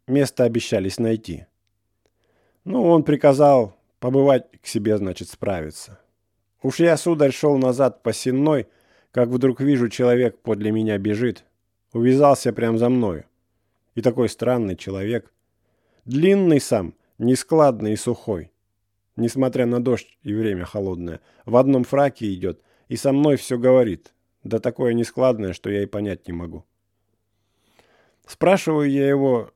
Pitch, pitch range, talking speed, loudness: 115 Hz, 100-130 Hz, 130 wpm, -20 LUFS